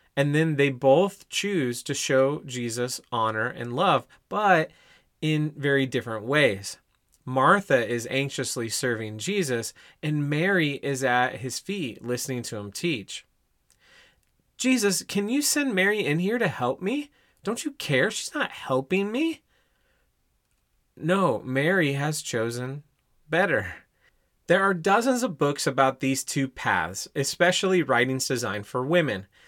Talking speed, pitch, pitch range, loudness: 135 wpm, 140 Hz, 125-180 Hz, -25 LUFS